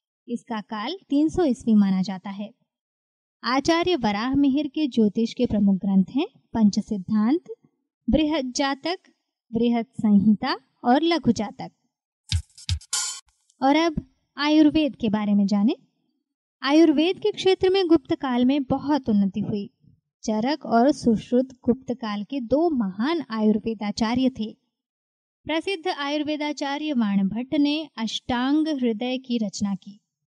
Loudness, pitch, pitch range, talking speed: -23 LUFS, 255 Hz, 215-300 Hz, 120 wpm